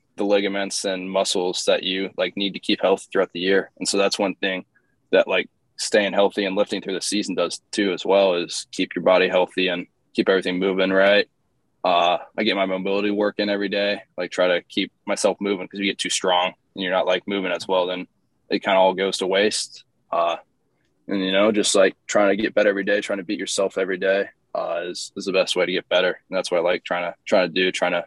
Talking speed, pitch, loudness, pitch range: 250 wpm, 95 Hz, -22 LUFS, 95-100 Hz